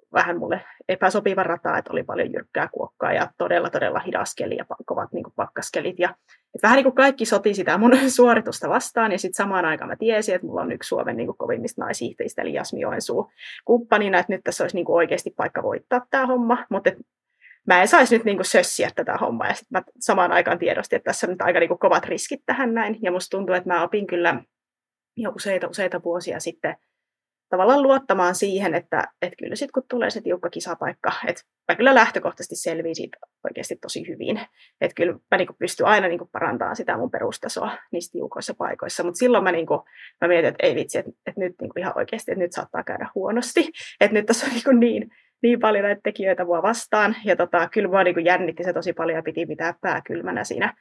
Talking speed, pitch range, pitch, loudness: 215 wpm, 180-245 Hz, 205 Hz, -22 LUFS